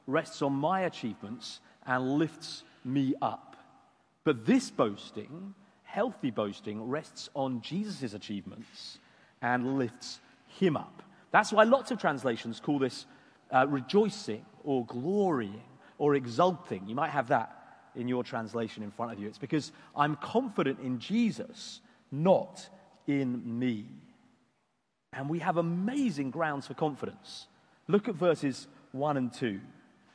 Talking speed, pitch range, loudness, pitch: 135 wpm, 125-190 Hz, -31 LUFS, 145 Hz